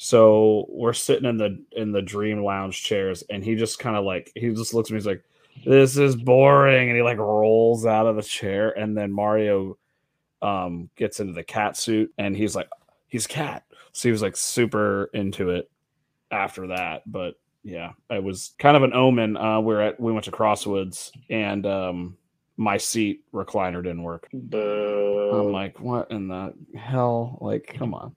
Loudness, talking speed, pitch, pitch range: -23 LUFS, 185 wpm, 105 Hz, 100-115 Hz